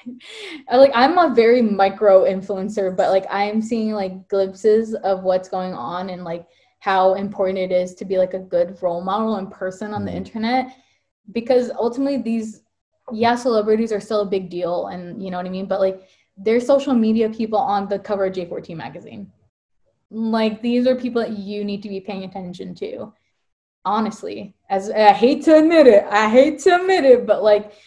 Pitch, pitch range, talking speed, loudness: 210 Hz, 190-235 Hz, 190 wpm, -18 LUFS